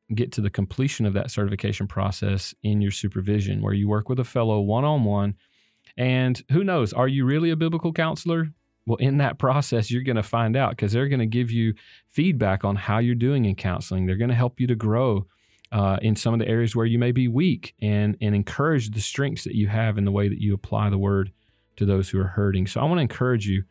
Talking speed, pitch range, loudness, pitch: 240 wpm, 100-125 Hz, -24 LUFS, 110 Hz